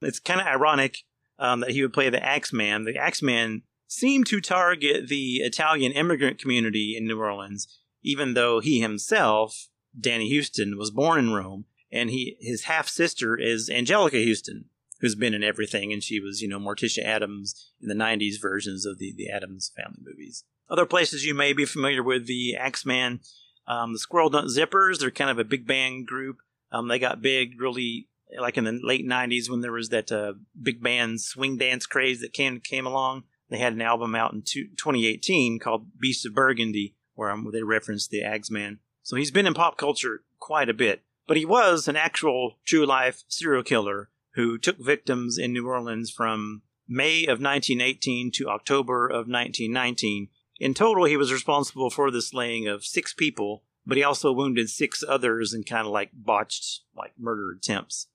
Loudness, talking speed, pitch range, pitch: -25 LUFS, 185 wpm, 110-135 Hz, 120 Hz